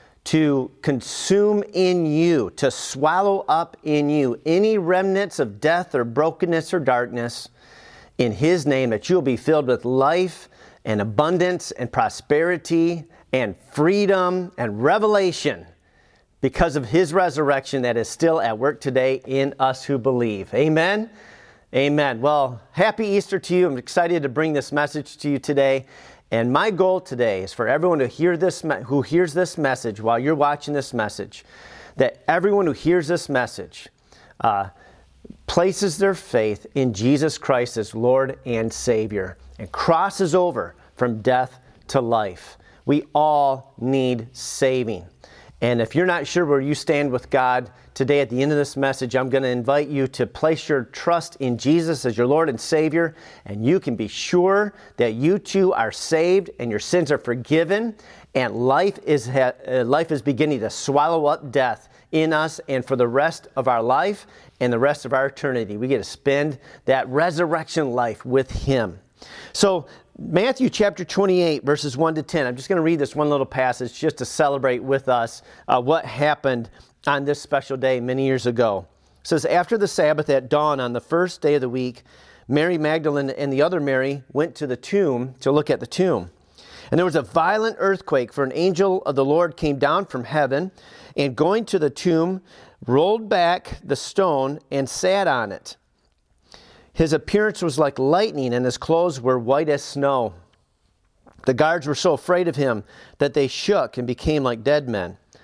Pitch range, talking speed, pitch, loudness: 130-170 Hz, 175 wpm, 145 Hz, -21 LUFS